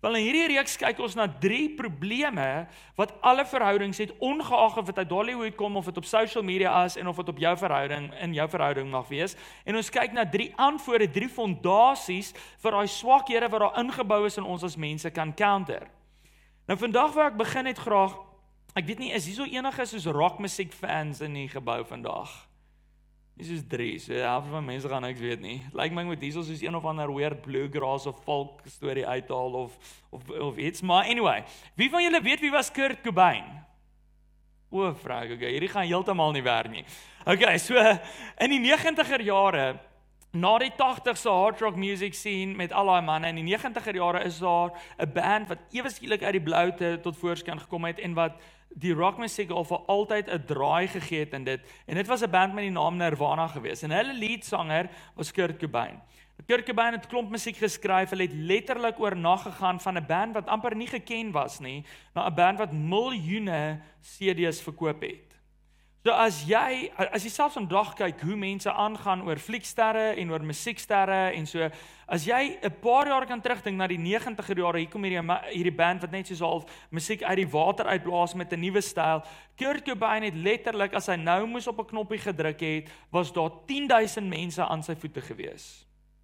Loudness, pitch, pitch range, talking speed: -27 LUFS, 185 Hz, 160-220 Hz, 195 wpm